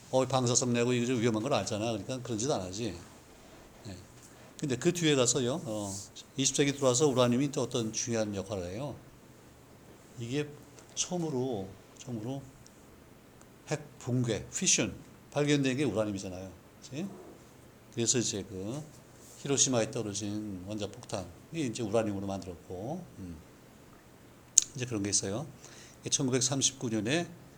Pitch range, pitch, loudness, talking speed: 105-135 Hz, 120 Hz, -31 LUFS, 270 characters per minute